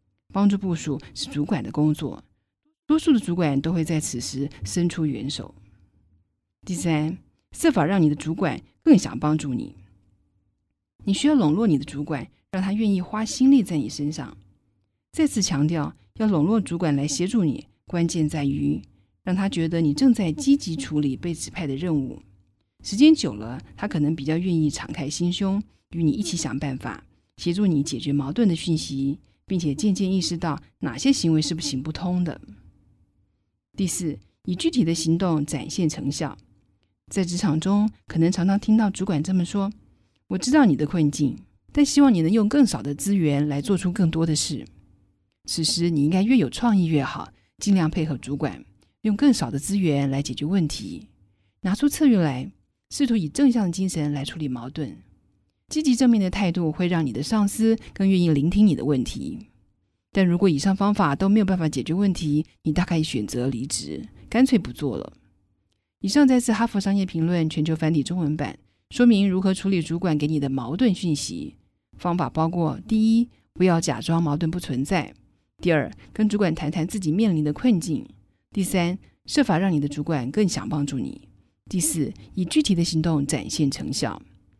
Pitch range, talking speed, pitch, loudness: 140-195 Hz, 265 characters per minute, 160 Hz, -23 LUFS